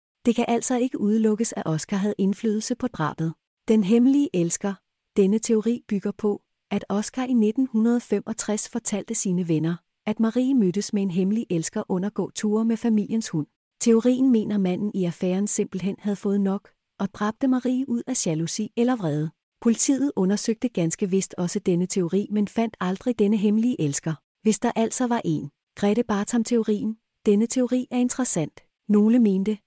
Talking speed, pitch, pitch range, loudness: 160 wpm, 210 Hz, 195-235 Hz, -24 LUFS